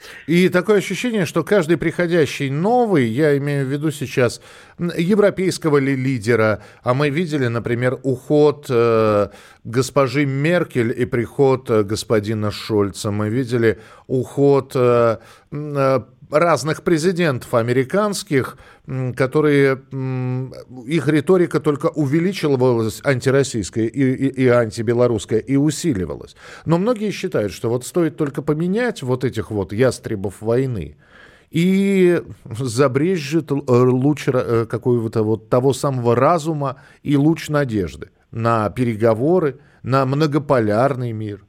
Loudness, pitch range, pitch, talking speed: -18 LUFS, 120-155 Hz, 135 Hz, 110 wpm